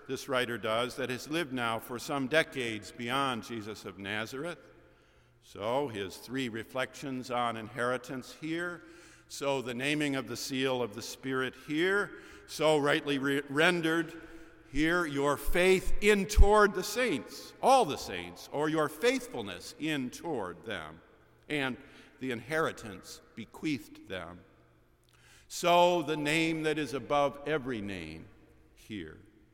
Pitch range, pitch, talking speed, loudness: 120-160 Hz, 140 Hz, 130 wpm, -31 LUFS